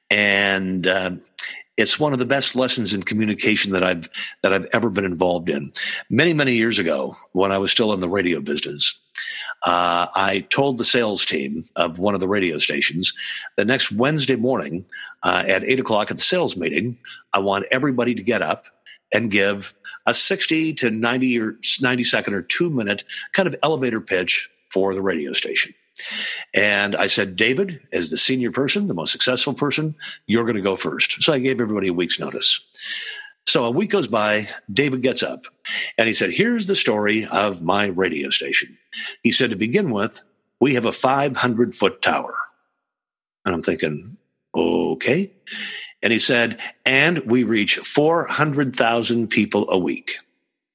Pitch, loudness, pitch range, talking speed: 120 Hz, -19 LUFS, 100-135 Hz, 175 wpm